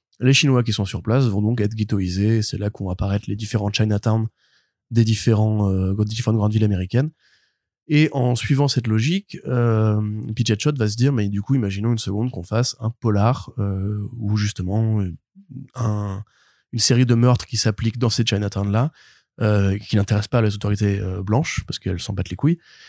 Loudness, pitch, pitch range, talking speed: -21 LUFS, 110 Hz, 105-125 Hz, 185 wpm